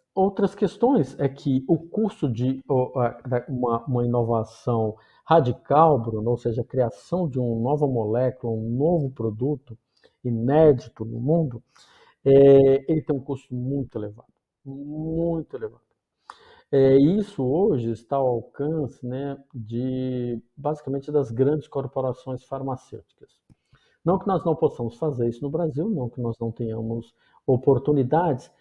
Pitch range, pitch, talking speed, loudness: 120-150 Hz, 135 Hz, 130 wpm, -24 LUFS